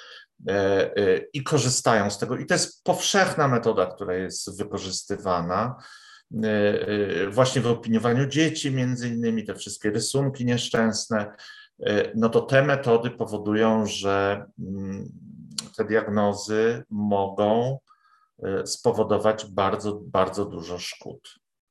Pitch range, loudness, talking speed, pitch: 105-140 Hz, -24 LUFS, 100 wpm, 115 Hz